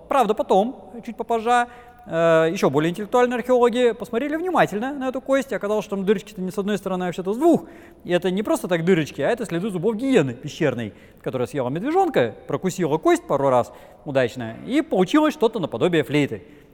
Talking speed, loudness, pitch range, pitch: 185 wpm, -22 LUFS, 165-245 Hz, 210 Hz